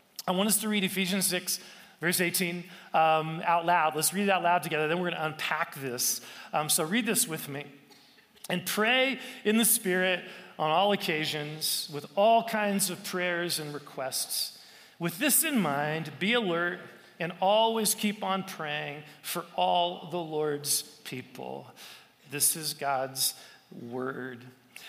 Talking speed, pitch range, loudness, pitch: 155 wpm, 150-195 Hz, -28 LUFS, 175 Hz